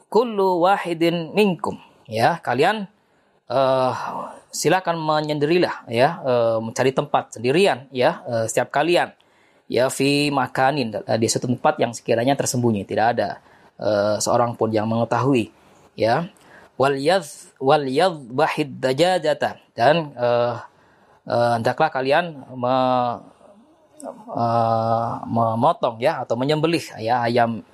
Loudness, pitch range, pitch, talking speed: -21 LUFS, 120-155 Hz, 130 Hz, 105 wpm